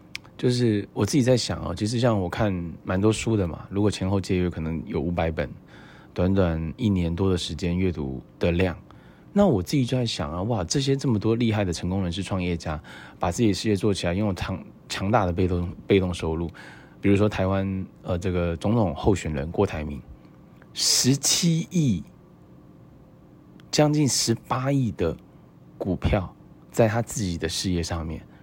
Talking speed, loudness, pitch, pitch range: 260 characters per minute, -25 LUFS, 95 Hz, 85-110 Hz